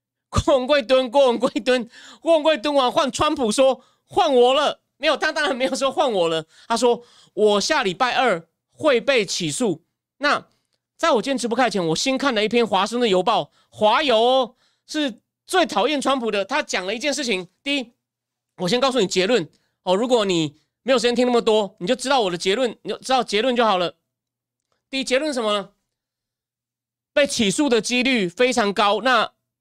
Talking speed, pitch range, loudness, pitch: 270 characters per minute, 200-265 Hz, -20 LUFS, 245 Hz